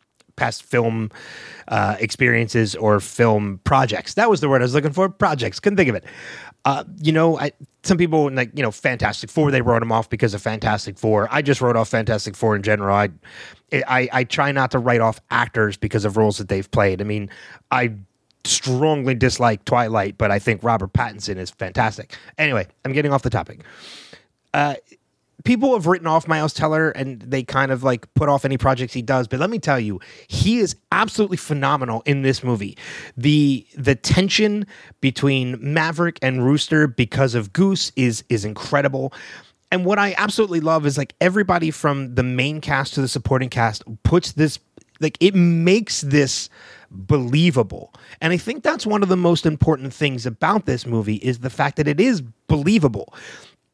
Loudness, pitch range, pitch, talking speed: -19 LUFS, 115-155 Hz, 130 Hz, 185 wpm